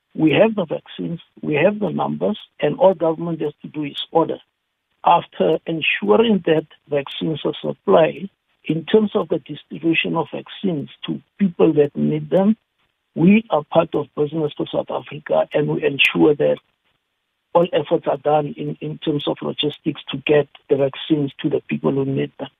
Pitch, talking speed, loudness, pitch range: 155 Hz, 175 wpm, -20 LUFS, 145-170 Hz